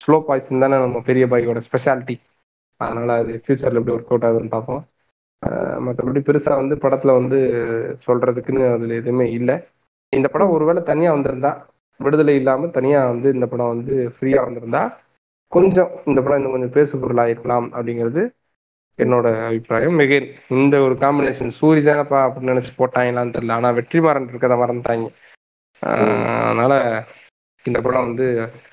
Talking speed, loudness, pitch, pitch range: 140 wpm, -18 LUFS, 130 Hz, 120-140 Hz